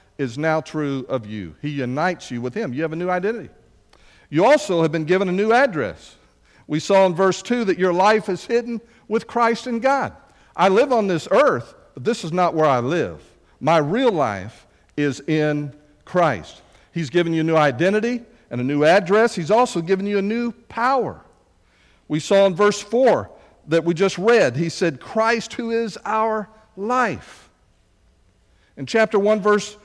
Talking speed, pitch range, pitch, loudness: 185 wpm, 150-220 Hz, 185 Hz, -20 LUFS